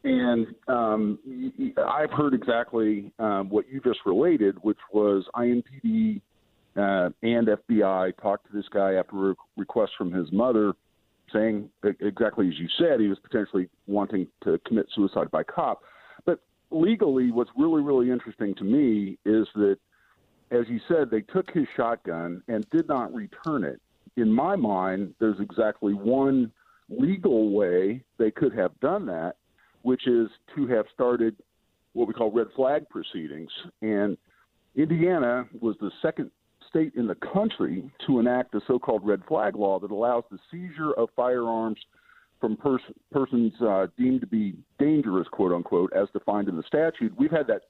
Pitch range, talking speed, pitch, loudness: 100-135 Hz, 160 wpm, 115 Hz, -26 LUFS